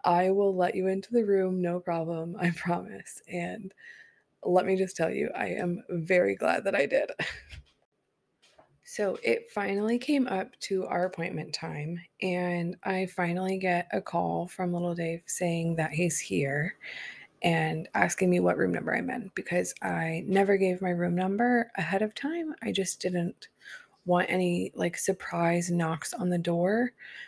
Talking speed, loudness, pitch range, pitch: 165 wpm, -29 LUFS, 175-195 Hz, 180 Hz